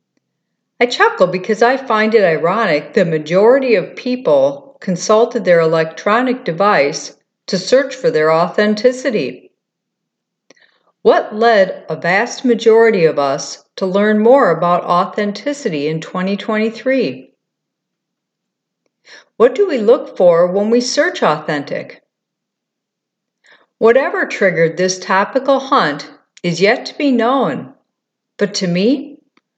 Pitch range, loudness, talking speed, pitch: 175-250 Hz, -14 LUFS, 115 wpm, 215 Hz